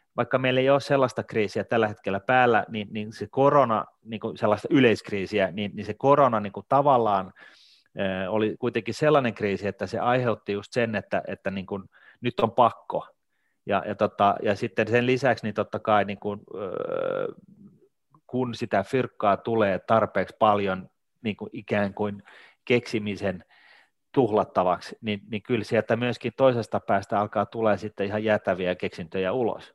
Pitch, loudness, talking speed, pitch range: 110 Hz, -25 LUFS, 160 wpm, 100-120 Hz